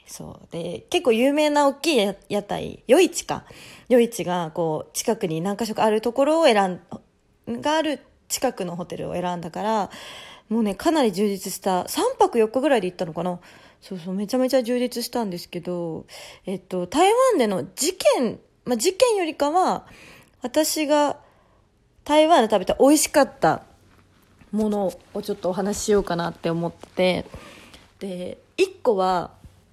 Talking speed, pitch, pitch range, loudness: 295 characters per minute, 220 Hz, 185-290 Hz, -22 LUFS